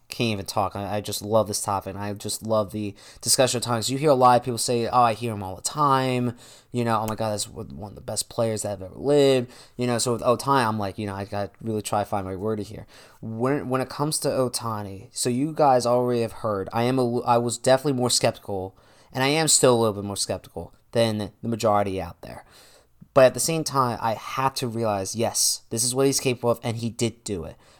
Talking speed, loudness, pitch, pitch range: 255 wpm, -24 LUFS, 115 Hz, 105-125 Hz